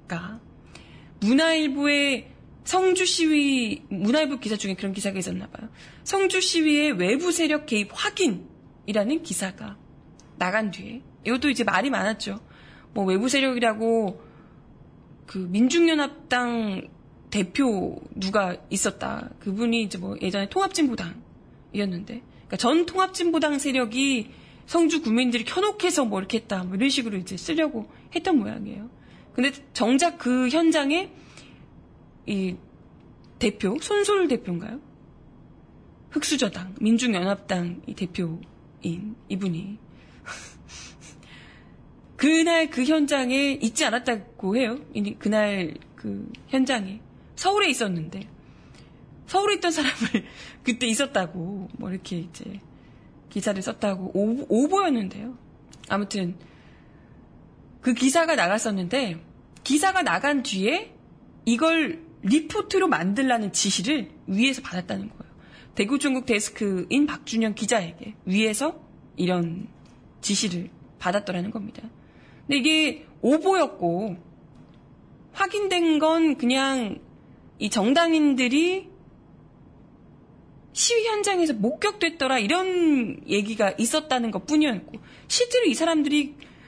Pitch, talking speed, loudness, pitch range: 240 Hz, 255 characters per minute, -24 LUFS, 200-300 Hz